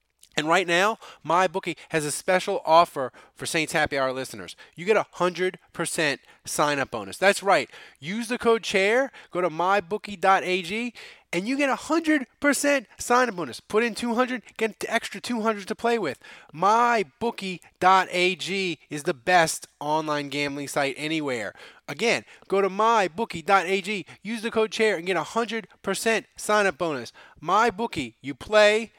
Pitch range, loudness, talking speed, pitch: 170-225 Hz, -24 LUFS, 150 wpm, 195 Hz